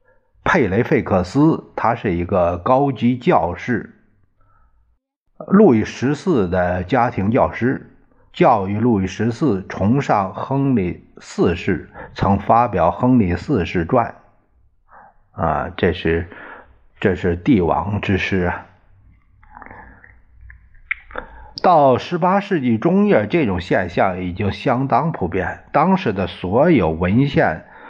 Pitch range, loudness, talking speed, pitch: 95-140 Hz, -18 LUFS, 165 characters per minute, 115 Hz